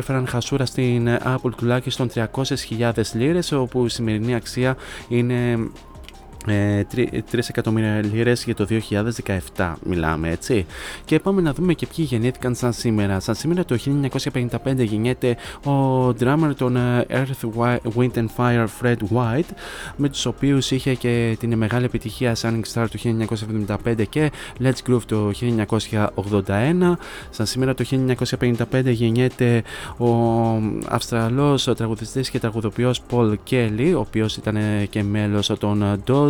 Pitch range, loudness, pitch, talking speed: 110-130 Hz, -21 LUFS, 120 Hz, 130 wpm